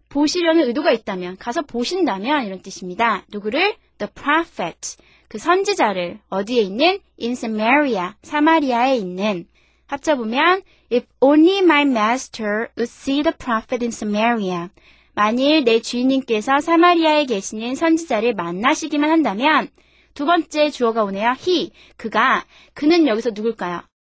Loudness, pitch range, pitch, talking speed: -18 LUFS, 220-310 Hz, 250 Hz, 390 characters per minute